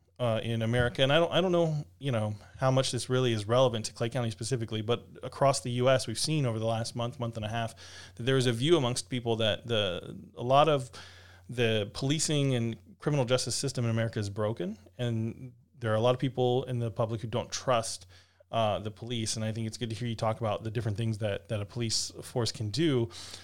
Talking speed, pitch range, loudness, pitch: 240 wpm, 110-125 Hz, -30 LUFS, 115 Hz